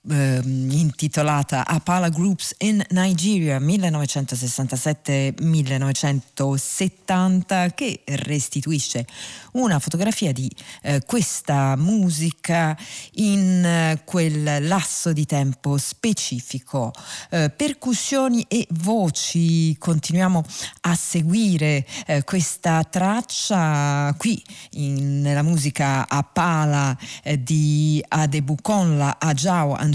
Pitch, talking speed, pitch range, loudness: 155 Hz, 85 wpm, 140-185 Hz, -21 LUFS